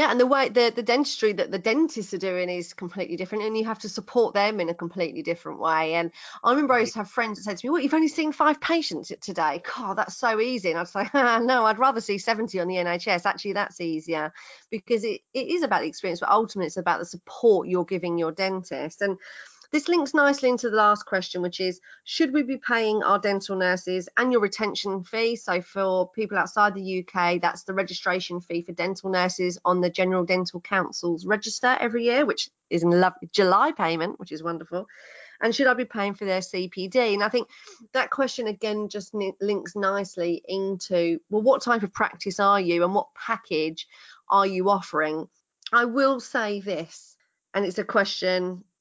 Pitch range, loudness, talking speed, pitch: 180-230 Hz, -25 LUFS, 210 wpm, 200 Hz